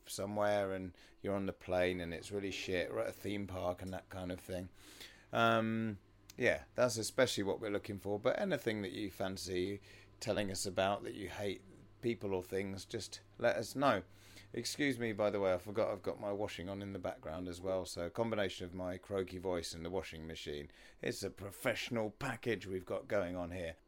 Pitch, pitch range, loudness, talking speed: 95 Hz, 90-105 Hz, -39 LUFS, 210 wpm